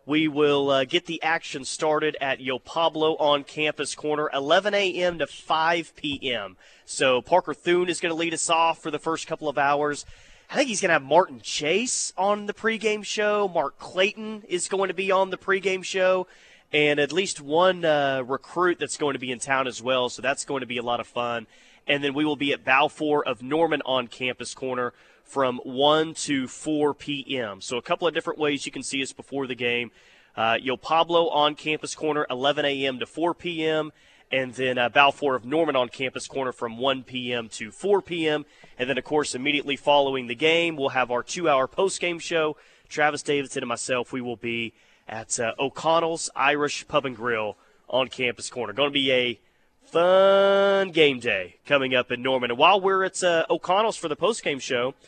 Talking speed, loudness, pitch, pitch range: 205 wpm, -24 LUFS, 145 Hz, 130-165 Hz